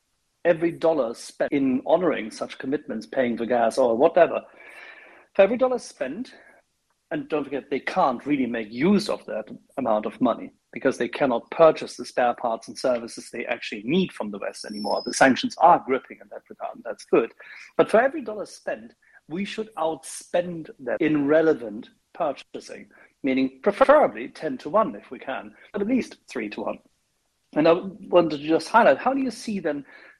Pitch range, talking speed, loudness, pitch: 140-215 Hz, 185 wpm, -24 LUFS, 165 Hz